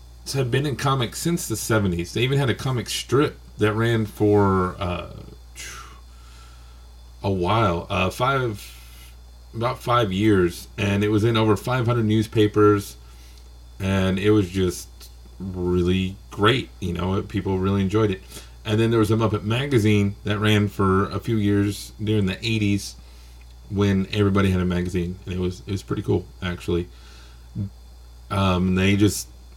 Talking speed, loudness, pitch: 150 wpm, -22 LUFS, 95 Hz